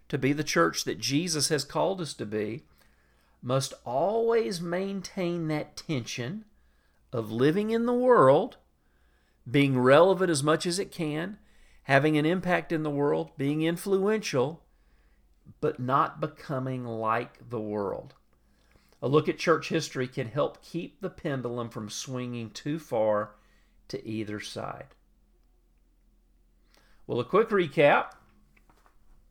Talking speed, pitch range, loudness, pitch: 130 wpm, 105-165 Hz, -28 LUFS, 135 Hz